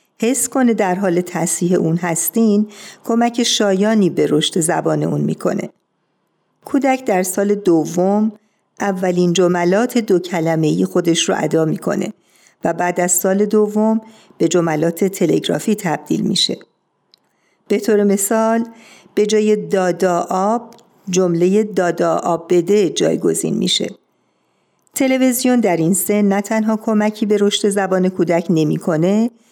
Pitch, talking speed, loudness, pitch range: 200 Hz, 125 wpm, -16 LUFS, 175-220 Hz